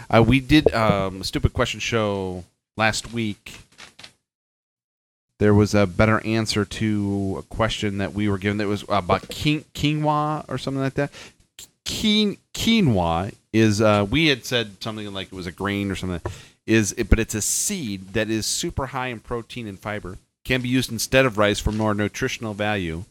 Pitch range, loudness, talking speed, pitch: 100-125 Hz, -22 LUFS, 175 wpm, 110 Hz